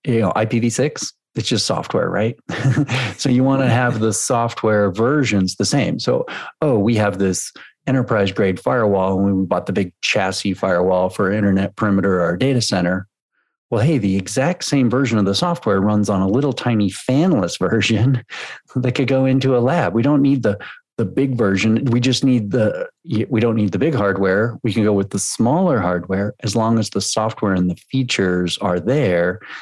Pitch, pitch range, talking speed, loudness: 110 Hz, 95-130 Hz, 190 wpm, -18 LUFS